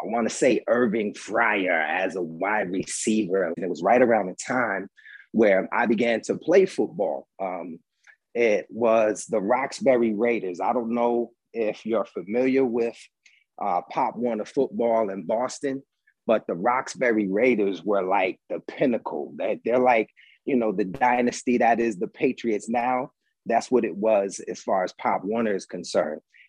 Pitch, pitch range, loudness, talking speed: 115 Hz, 110-125 Hz, -24 LUFS, 165 wpm